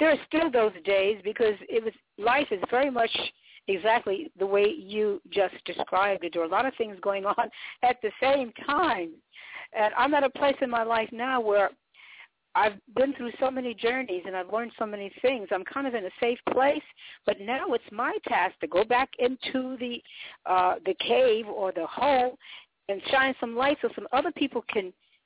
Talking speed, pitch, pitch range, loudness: 200 wpm, 235 Hz, 205-265 Hz, -27 LUFS